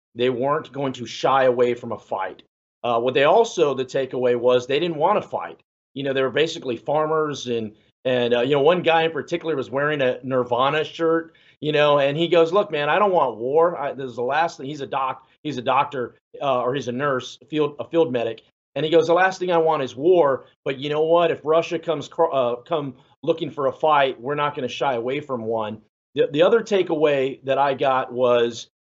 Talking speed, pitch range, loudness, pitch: 235 wpm, 125-160 Hz, -21 LUFS, 140 Hz